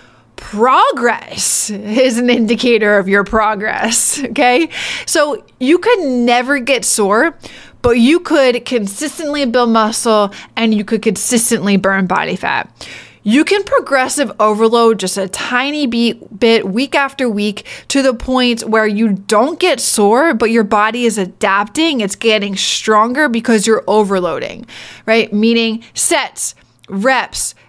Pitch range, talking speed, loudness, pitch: 210-260 Hz, 130 wpm, -13 LUFS, 230 Hz